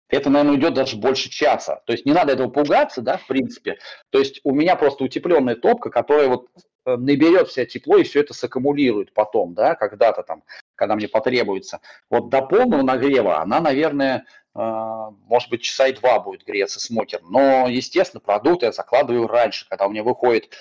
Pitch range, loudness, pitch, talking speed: 120-145 Hz, -19 LUFS, 130 Hz, 180 wpm